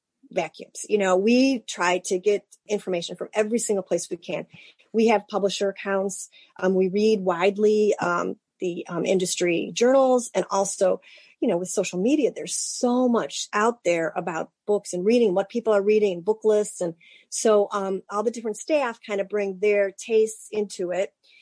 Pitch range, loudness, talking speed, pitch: 185-220 Hz, -24 LUFS, 175 wpm, 205 Hz